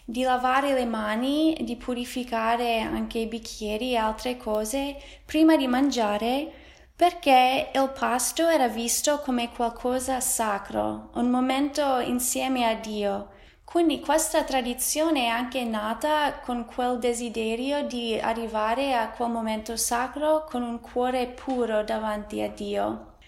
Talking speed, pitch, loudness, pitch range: 130 wpm, 245 Hz, -26 LUFS, 225-265 Hz